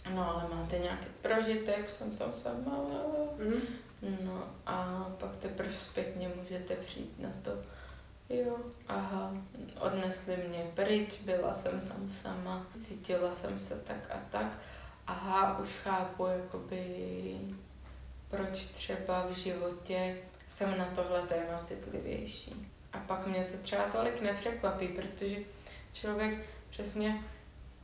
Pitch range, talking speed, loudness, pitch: 180-200 Hz, 120 wpm, -37 LUFS, 185 Hz